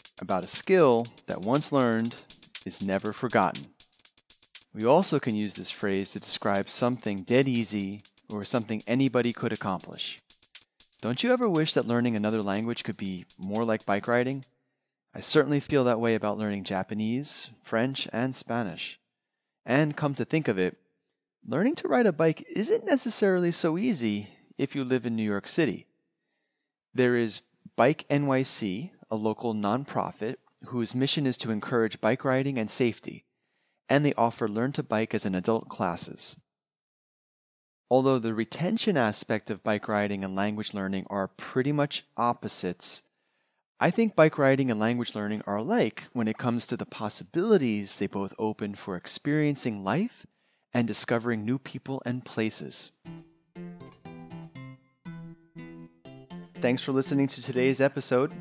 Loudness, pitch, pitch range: -28 LUFS, 120 Hz, 105-145 Hz